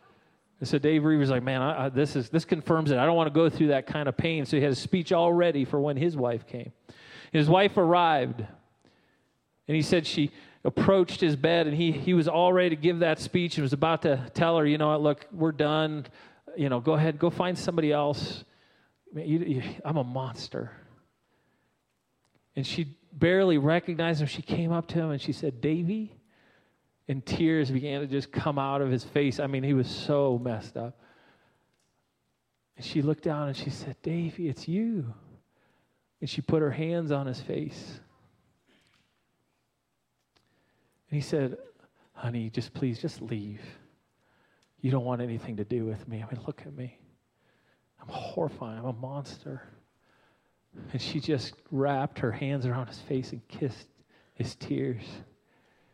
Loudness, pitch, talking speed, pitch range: -28 LUFS, 150 Hz, 180 wpm, 130-165 Hz